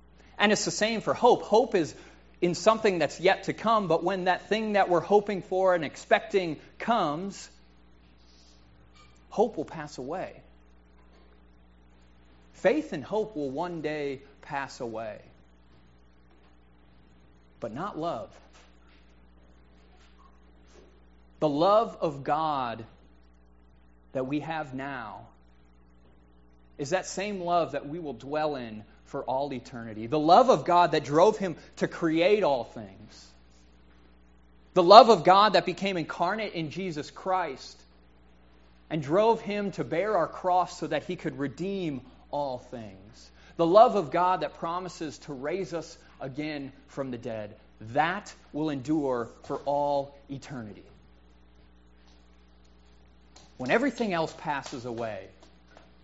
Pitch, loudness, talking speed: 135 Hz, -27 LUFS, 125 wpm